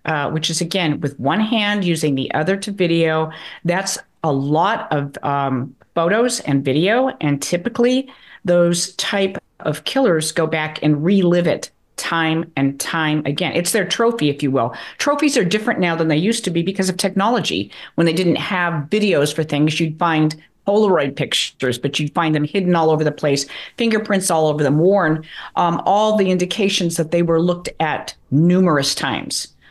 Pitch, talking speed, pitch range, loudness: 170 Hz, 180 wpm, 150-195 Hz, -18 LUFS